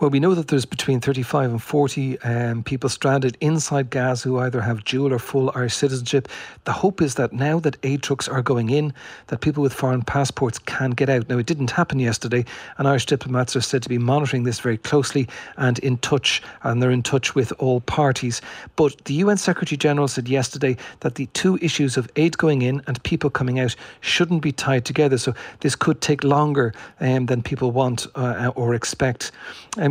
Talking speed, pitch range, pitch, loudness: 205 wpm, 125-145 Hz, 135 Hz, -21 LUFS